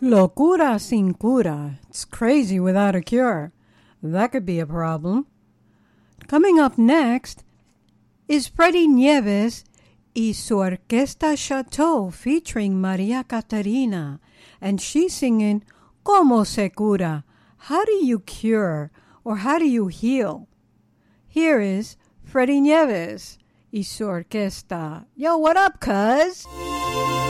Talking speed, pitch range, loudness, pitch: 110 wpm, 185-280 Hz, -20 LUFS, 225 Hz